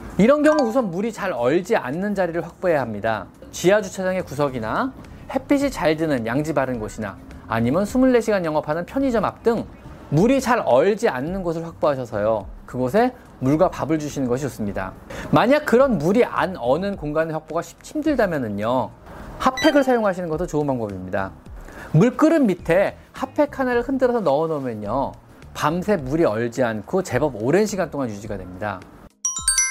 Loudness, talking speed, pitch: -21 LUFS, 345 characters per minute, 170 Hz